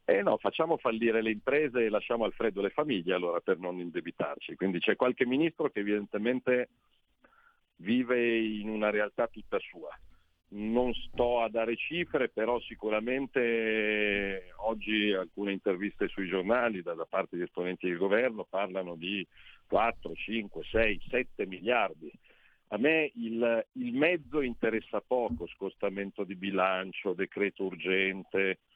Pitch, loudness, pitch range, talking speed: 105 Hz, -31 LUFS, 95-120 Hz, 140 wpm